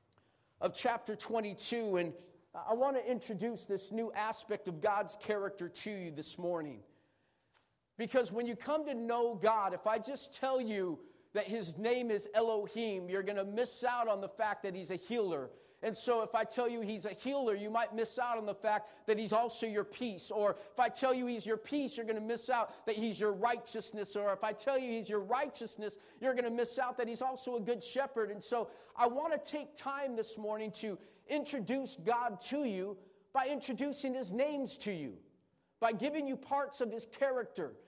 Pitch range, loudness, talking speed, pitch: 210-250 Hz, -37 LUFS, 205 wpm, 225 Hz